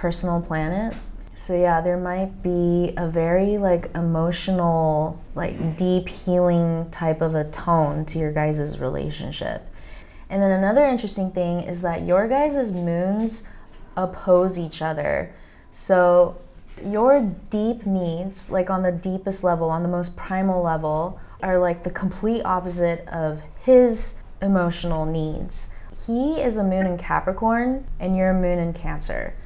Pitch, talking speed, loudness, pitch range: 180 Hz, 145 wpm, -22 LUFS, 170-190 Hz